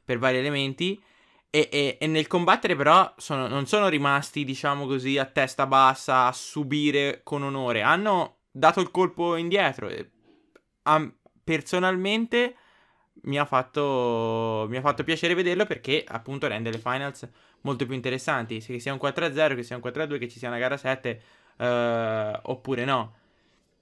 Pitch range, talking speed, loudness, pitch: 125-155 Hz, 160 wpm, -25 LUFS, 140 Hz